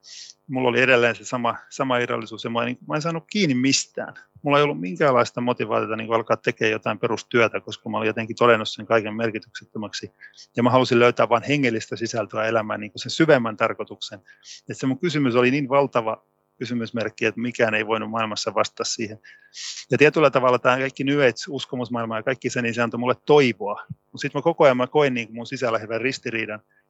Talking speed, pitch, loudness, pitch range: 195 wpm, 120 Hz, -22 LUFS, 115-135 Hz